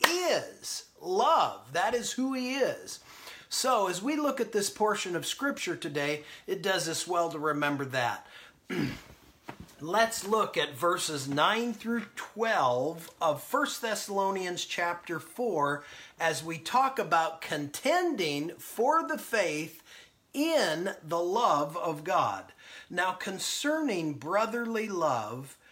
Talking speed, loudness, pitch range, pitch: 125 wpm, -30 LUFS, 165-250 Hz, 195 Hz